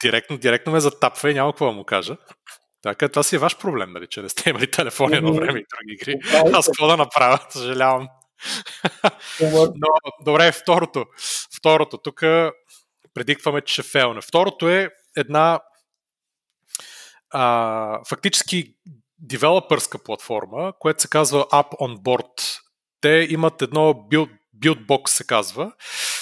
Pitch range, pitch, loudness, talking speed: 130-160 Hz, 150 Hz, -19 LUFS, 140 wpm